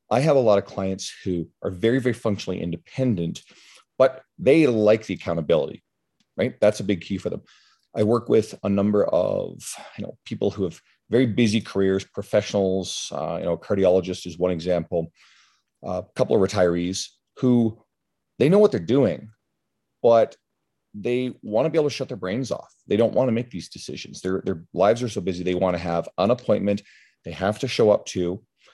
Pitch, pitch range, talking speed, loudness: 95 Hz, 90-110 Hz, 195 wpm, -23 LUFS